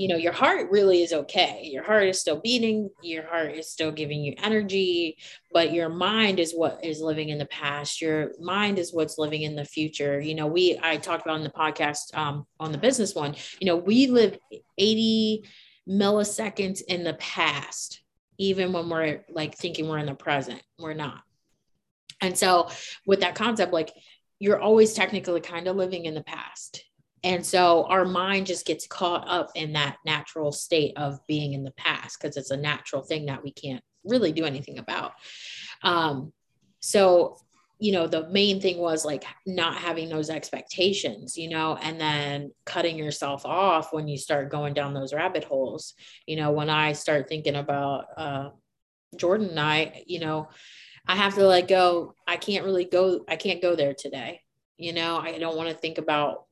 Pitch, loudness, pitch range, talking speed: 165 Hz, -25 LUFS, 150-185 Hz, 190 wpm